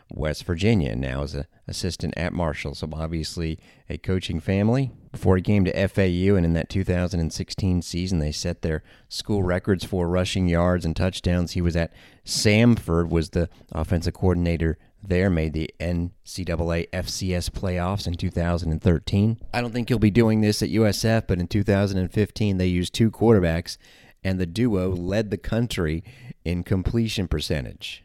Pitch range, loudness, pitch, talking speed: 85-105 Hz, -24 LUFS, 90 Hz, 160 wpm